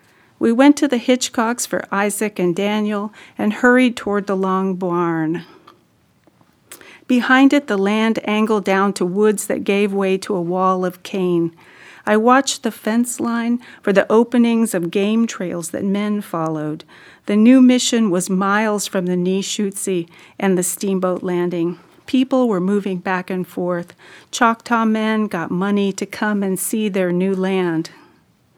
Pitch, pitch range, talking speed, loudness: 200 Hz, 185-225 Hz, 155 wpm, -18 LUFS